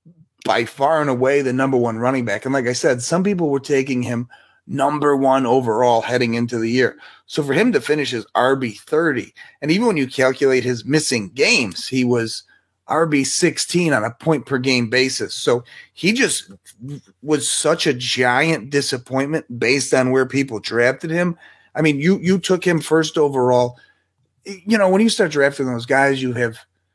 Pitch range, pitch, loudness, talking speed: 125-155 Hz, 135 Hz, -18 LUFS, 180 wpm